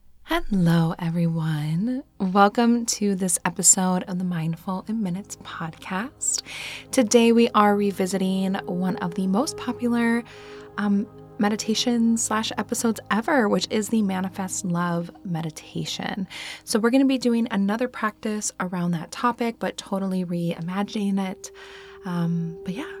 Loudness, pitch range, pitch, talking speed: -24 LUFS, 180-230 Hz, 195 Hz, 130 wpm